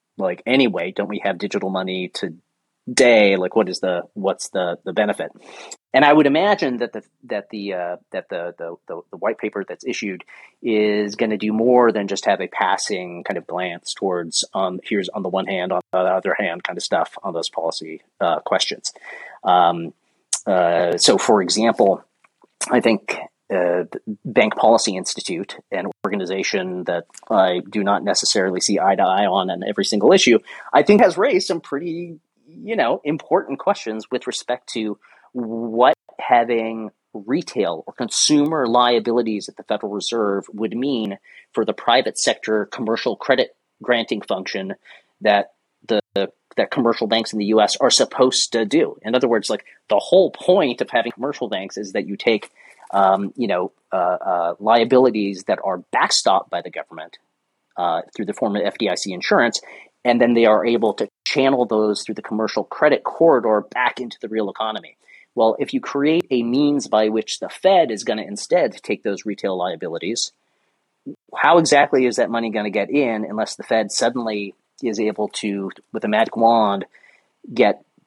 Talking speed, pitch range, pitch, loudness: 180 wpm, 100-120 Hz, 110 Hz, -19 LUFS